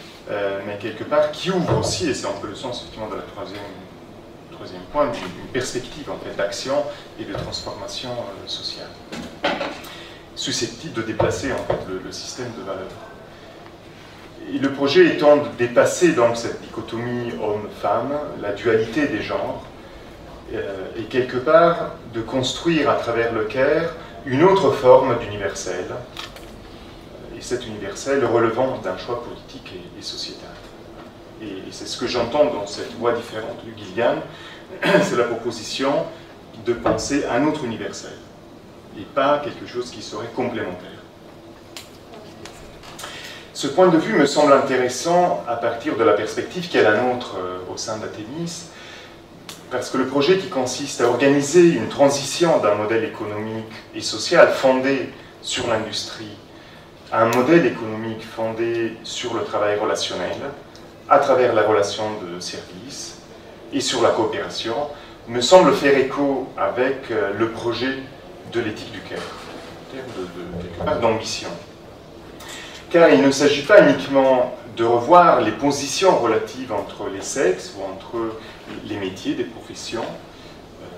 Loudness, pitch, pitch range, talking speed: -20 LUFS, 120 Hz, 110-145 Hz, 140 wpm